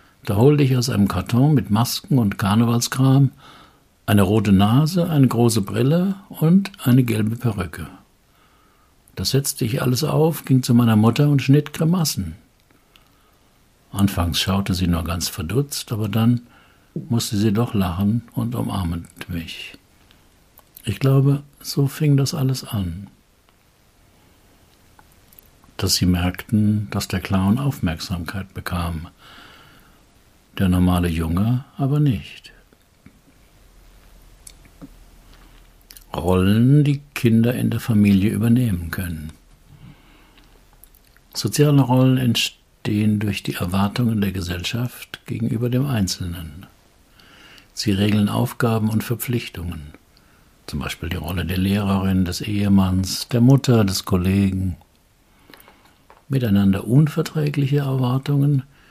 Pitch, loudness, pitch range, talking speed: 105 Hz, -20 LUFS, 95-130 Hz, 110 wpm